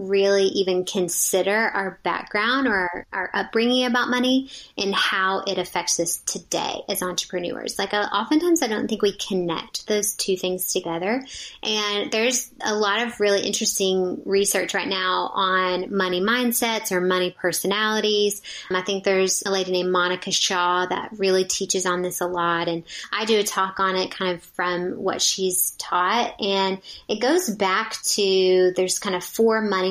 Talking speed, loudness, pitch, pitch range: 170 wpm, -22 LUFS, 195 Hz, 185-210 Hz